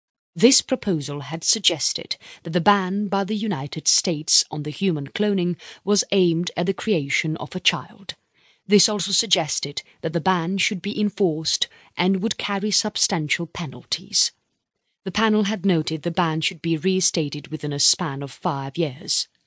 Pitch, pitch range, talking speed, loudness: 180 Hz, 160-205 Hz, 160 wpm, -22 LUFS